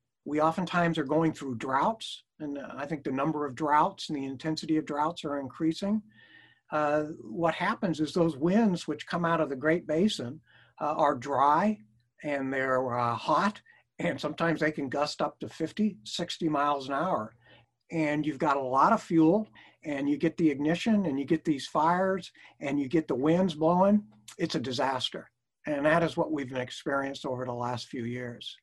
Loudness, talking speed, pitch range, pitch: -29 LUFS, 185 wpm, 140-170 Hz, 155 Hz